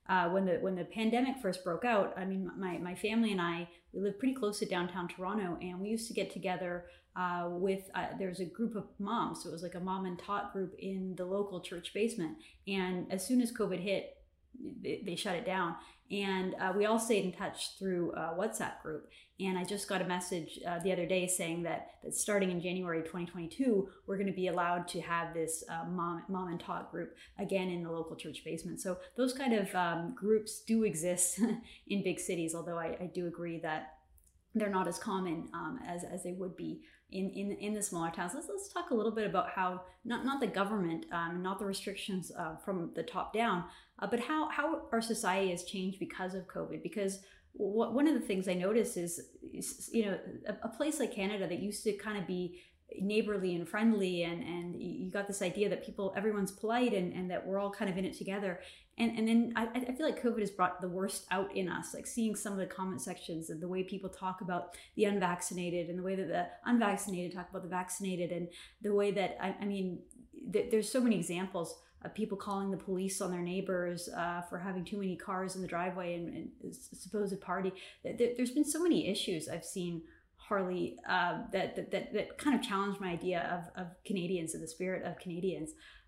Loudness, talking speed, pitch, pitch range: -36 LUFS, 225 wpm, 190 Hz, 180-210 Hz